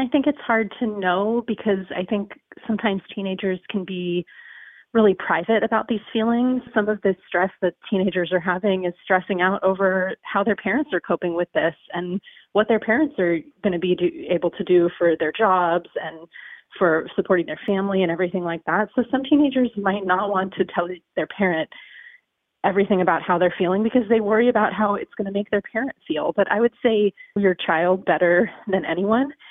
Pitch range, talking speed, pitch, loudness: 180-220 Hz, 195 wpm, 195 Hz, -22 LUFS